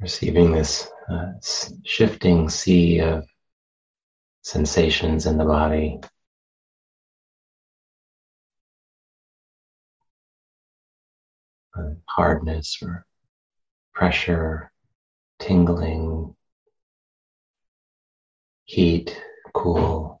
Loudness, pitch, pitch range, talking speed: -21 LUFS, 80 Hz, 80-85 Hz, 50 wpm